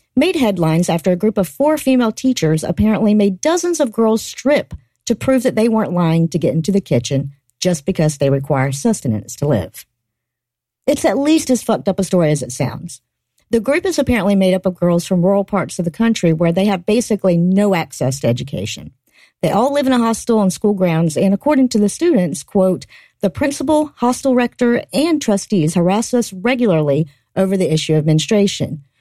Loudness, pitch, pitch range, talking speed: -16 LUFS, 195 Hz, 160-240 Hz, 195 wpm